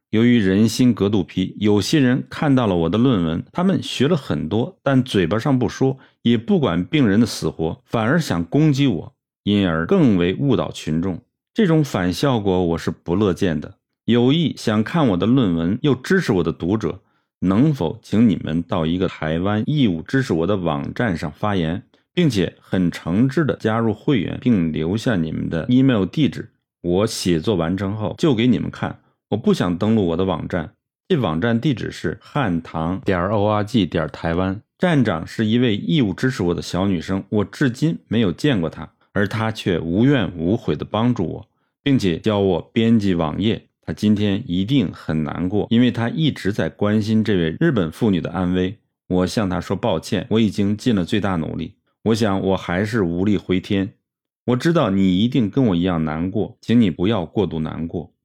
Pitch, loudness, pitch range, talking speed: 105 Hz, -20 LUFS, 90-120 Hz, 275 characters per minute